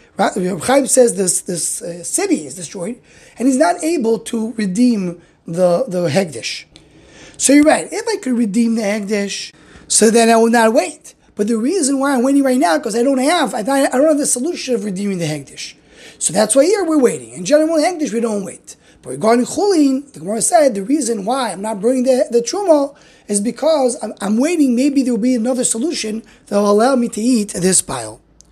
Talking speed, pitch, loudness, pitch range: 210 wpm, 235 Hz, -15 LUFS, 205-275 Hz